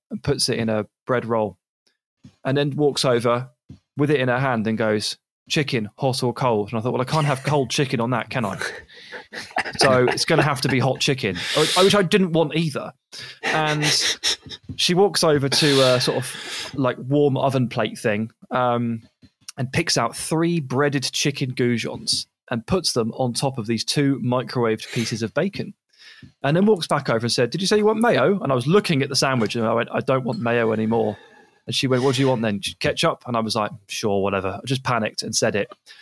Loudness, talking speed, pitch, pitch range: -21 LUFS, 220 wpm, 130 Hz, 115-150 Hz